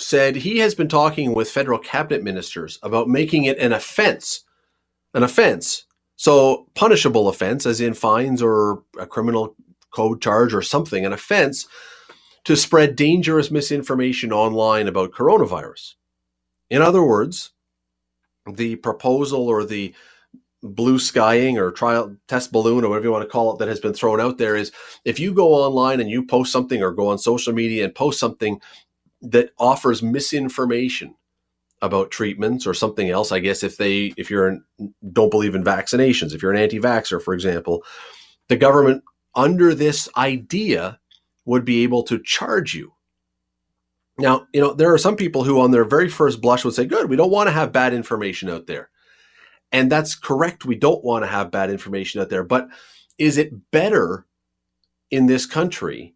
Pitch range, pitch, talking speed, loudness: 100-135 Hz, 120 Hz, 170 wpm, -19 LUFS